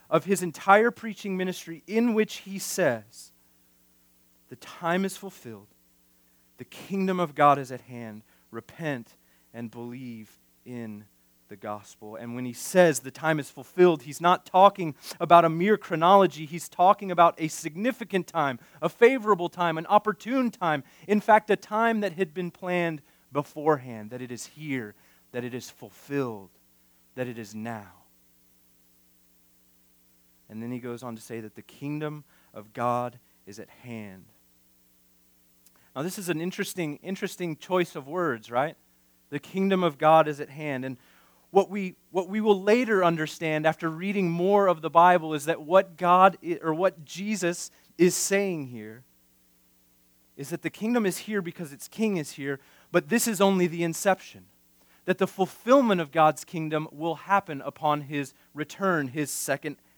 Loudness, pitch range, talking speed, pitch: -26 LUFS, 110-185 Hz, 160 wpm, 155 Hz